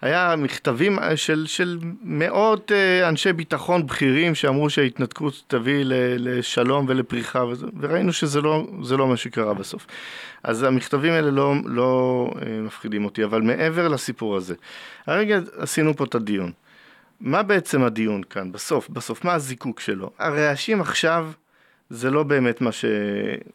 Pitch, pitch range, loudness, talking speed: 140 Hz, 125-165 Hz, -22 LUFS, 135 wpm